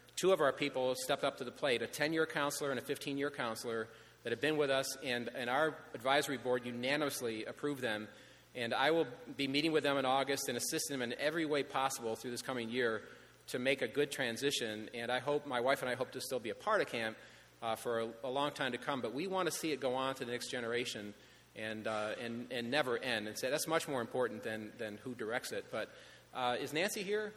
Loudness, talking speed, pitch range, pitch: -37 LUFS, 245 wpm, 120-145 Hz, 130 Hz